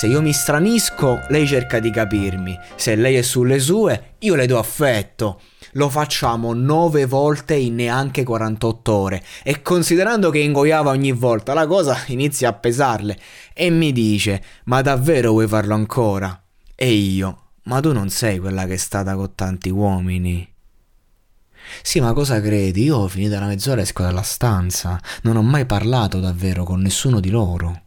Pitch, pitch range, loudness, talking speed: 115 Hz, 95-140 Hz, -18 LUFS, 170 wpm